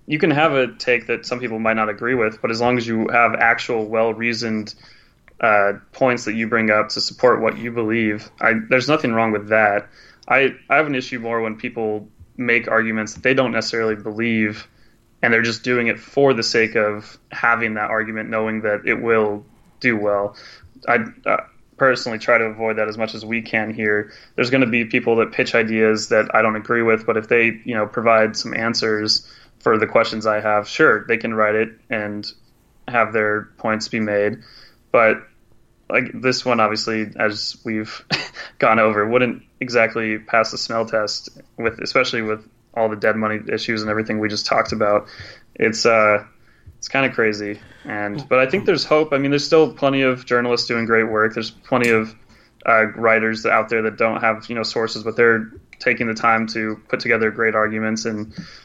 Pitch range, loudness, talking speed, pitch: 110-115 Hz, -19 LUFS, 200 wpm, 110 Hz